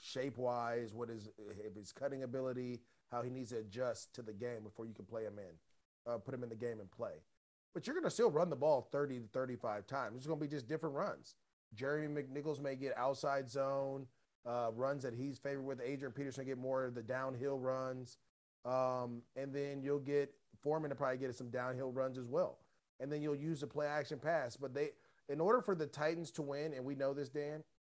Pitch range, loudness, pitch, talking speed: 120-145 Hz, -41 LUFS, 130 Hz, 215 wpm